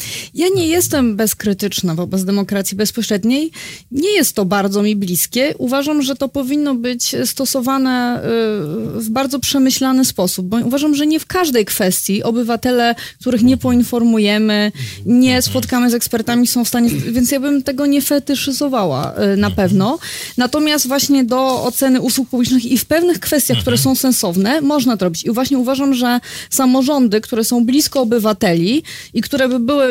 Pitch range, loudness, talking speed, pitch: 215-275 Hz, -15 LUFS, 155 wpm, 250 Hz